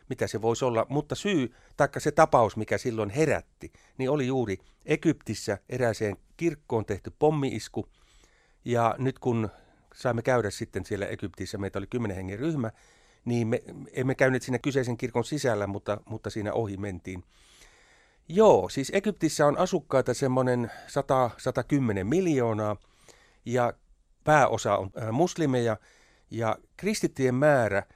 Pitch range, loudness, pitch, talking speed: 105-140 Hz, -27 LUFS, 120 Hz, 130 wpm